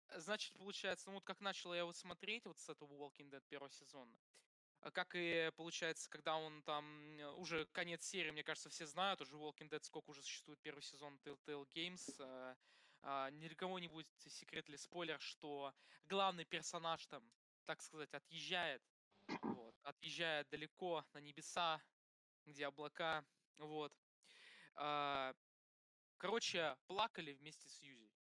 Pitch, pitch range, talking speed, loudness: 155 Hz, 145-175 Hz, 150 wpm, -47 LUFS